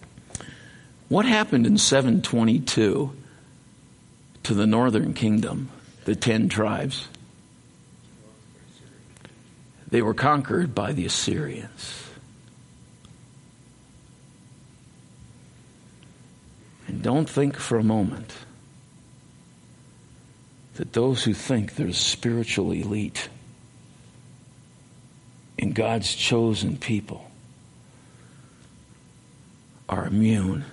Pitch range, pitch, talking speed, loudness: 100-130 Hz, 110 Hz, 70 wpm, -24 LUFS